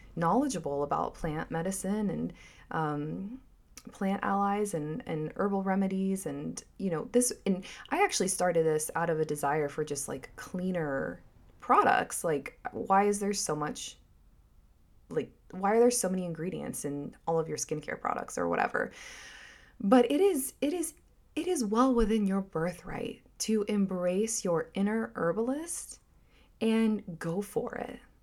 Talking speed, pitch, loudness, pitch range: 150 wpm, 195 Hz, -31 LUFS, 165-235 Hz